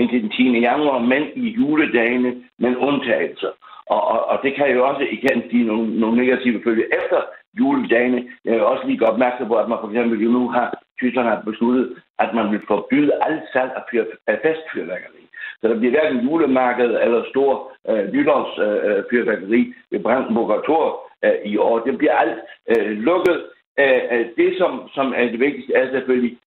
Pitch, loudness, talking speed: 125 Hz, -19 LUFS, 180 wpm